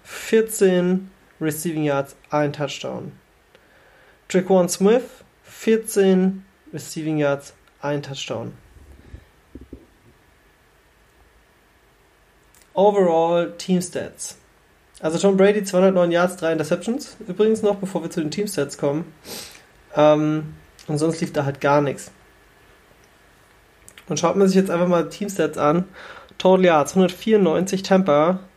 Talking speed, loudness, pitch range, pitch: 115 wpm, -20 LUFS, 150-190 Hz, 175 Hz